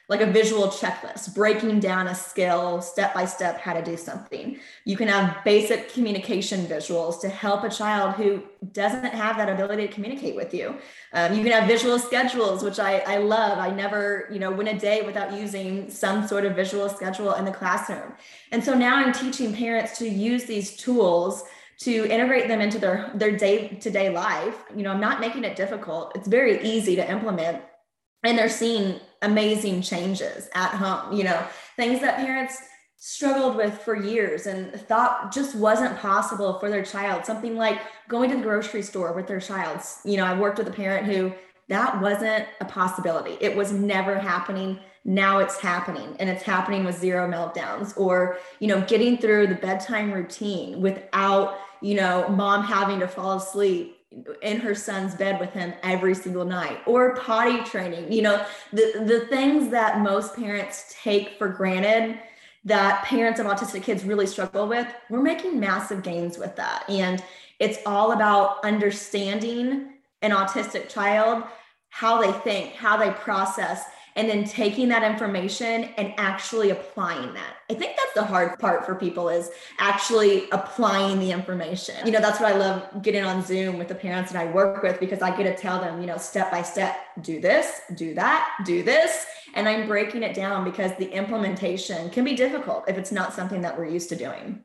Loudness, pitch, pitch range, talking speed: -24 LUFS, 200 Hz, 190-220 Hz, 185 wpm